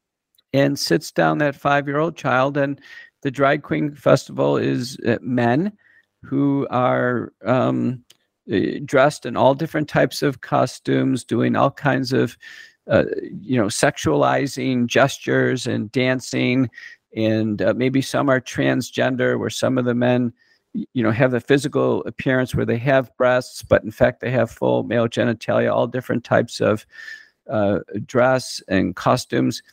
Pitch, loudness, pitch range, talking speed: 130 Hz, -20 LUFS, 115-140 Hz, 145 wpm